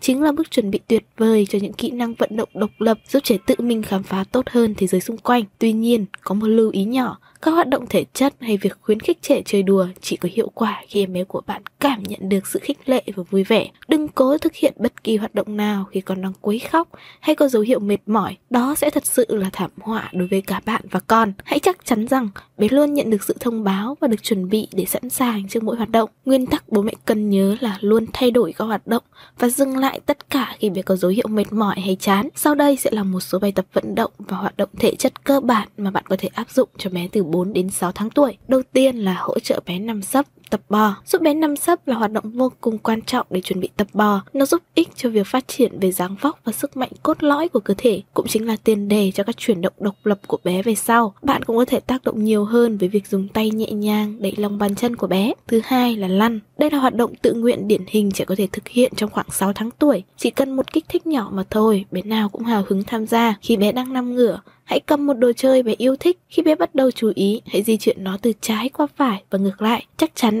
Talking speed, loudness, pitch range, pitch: 275 wpm, -20 LUFS, 200-255 Hz, 225 Hz